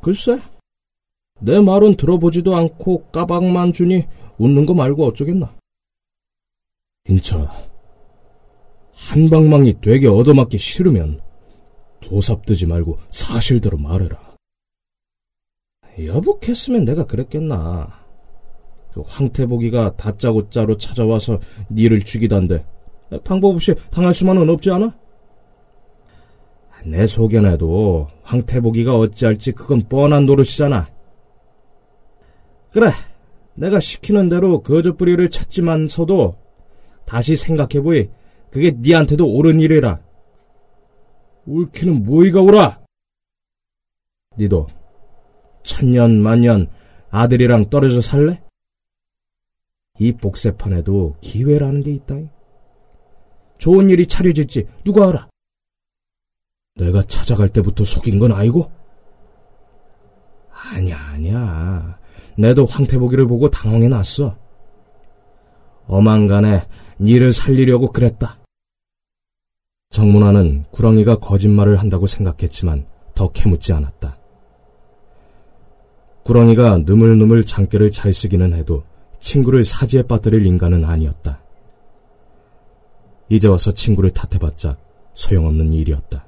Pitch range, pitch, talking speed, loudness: 95-140 Hz, 110 Hz, 230 characters per minute, -14 LUFS